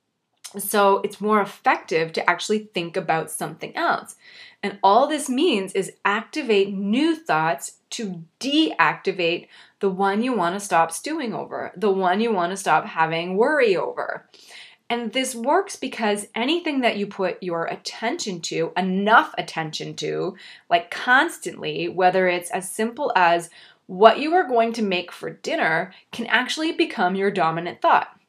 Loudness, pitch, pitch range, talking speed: -22 LUFS, 205 Hz, 180-245 Hz, 155 wpm